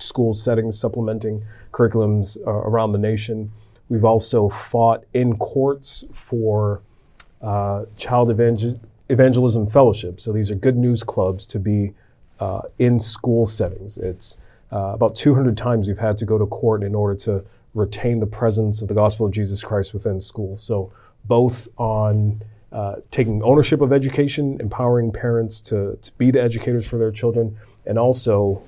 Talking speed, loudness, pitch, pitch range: 160 wpm, -20 LUFS, 110 Hz, 105-120 Hz